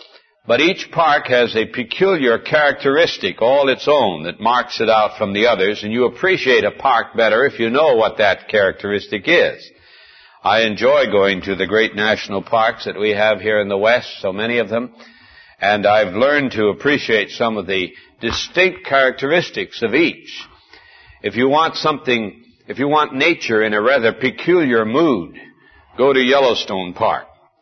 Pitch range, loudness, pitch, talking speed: 105-140 Hz, -16 LUFS, 115 Hz, 170 wpm